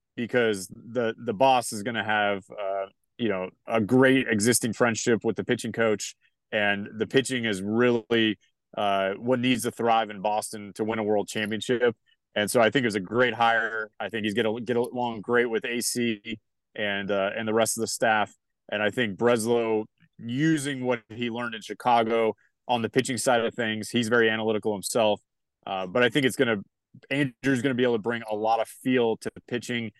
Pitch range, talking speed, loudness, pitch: 110-125 Hz, 205 wpm, -26 LUFS, 115 Hz